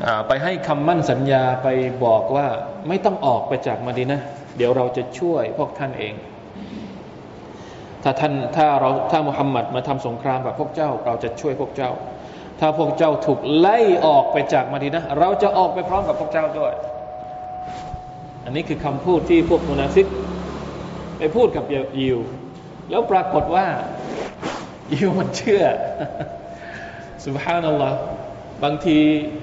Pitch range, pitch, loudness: 125-160 Hz, 145 Hz, -20 LUFS